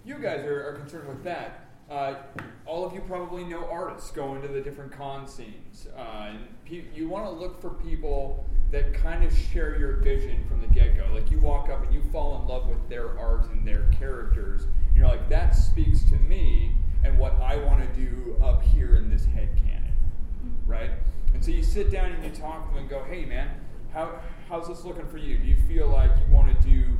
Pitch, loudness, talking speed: 105 Hz, -28 LUFS, 225 wpm